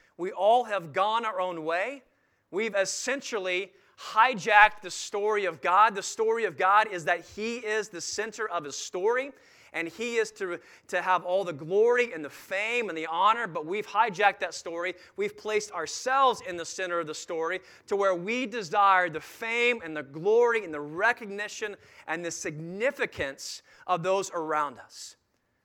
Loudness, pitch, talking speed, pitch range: -27 LUFS, 200 Hz, 175 wpm, 175-235 Hz